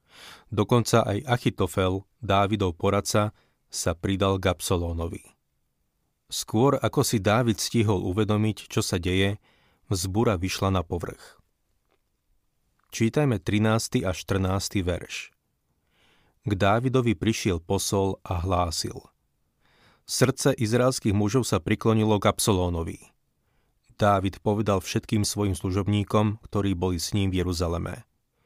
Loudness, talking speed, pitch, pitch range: -25 LUFS, 105 wpm, 100 Hz, 95-110 Hz